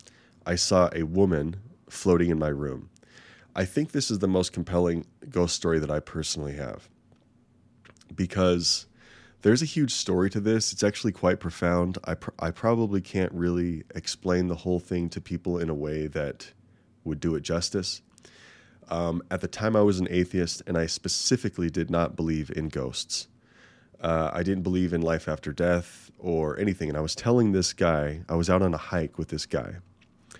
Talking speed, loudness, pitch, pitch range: 185 wpm, -27 LUFS, 90 Hz, 80-100 Hz